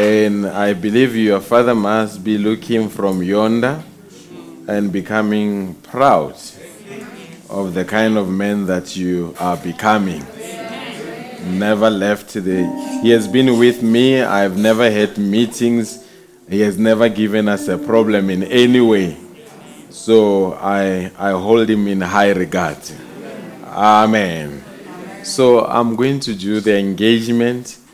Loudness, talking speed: -15 LUFS, 130 wpm